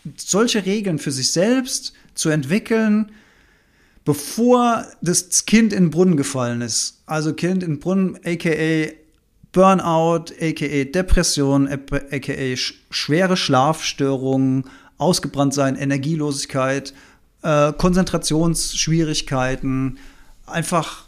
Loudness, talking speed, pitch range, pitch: -19 LUFS, 90 wpm, 140-185 Hz, 155 Hz